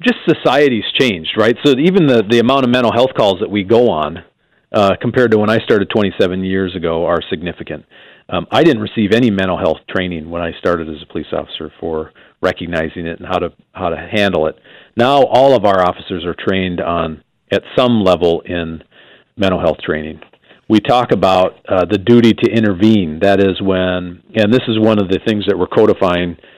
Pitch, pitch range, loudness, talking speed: 95 Hz, 85-110 Hz, -14 LUFS, 200 wpm